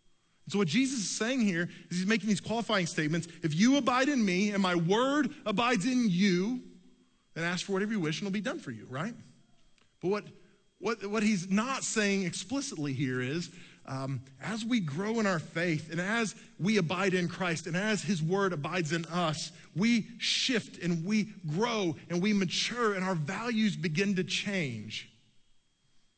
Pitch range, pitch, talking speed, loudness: 170-220 Hz, 195 Hz, 185 wpm, -31 LUFS